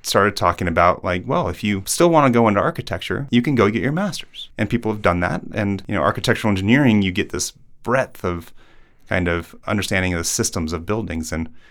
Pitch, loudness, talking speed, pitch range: 100 Hz, -20 LUFS, 220 wpm, 90-115 Hz